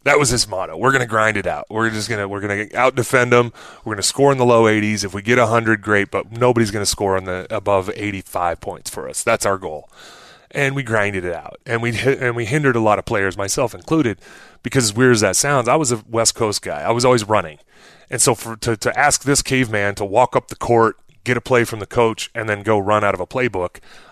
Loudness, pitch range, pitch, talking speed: -18 LUFS, 105-125 Hz, 115 Hz, 265 wpm